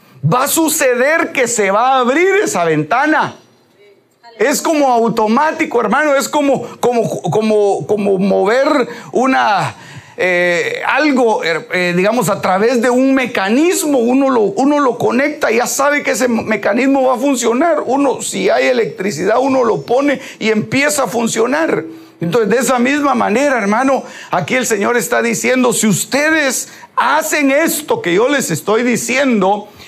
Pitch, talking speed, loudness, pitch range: 250 Hz, 150 wpm, -13 LUFS, 215-280 Hz